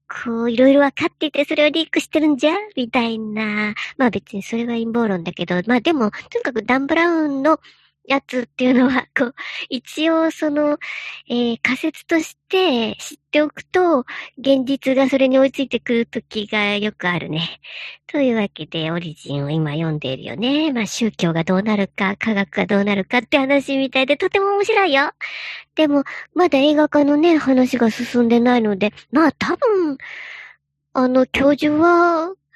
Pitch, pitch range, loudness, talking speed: 260 Hz, 215-300 Hz, -18 LUFS, 335 characters per minute